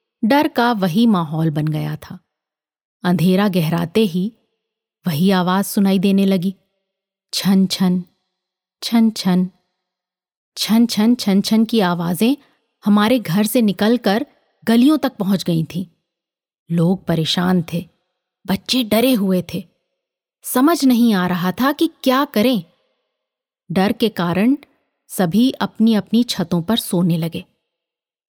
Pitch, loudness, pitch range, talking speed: 195 Hz, -17 LUFS, 180-230 Hz, 125 wpm